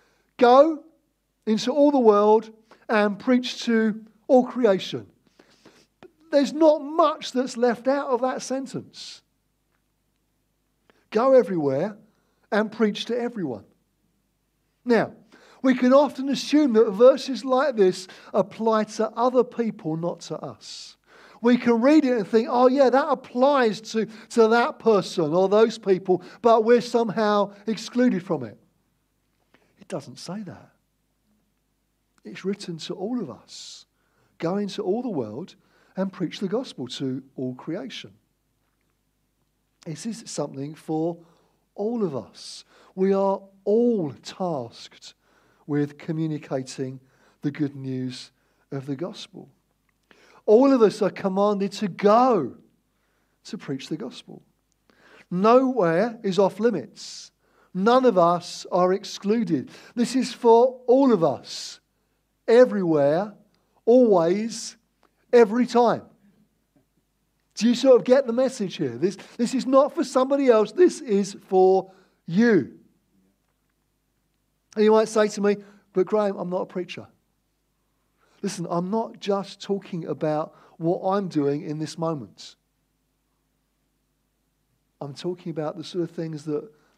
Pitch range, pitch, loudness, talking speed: 175-240 Hz, 210 Hz, -22 LUFS, 130 wpm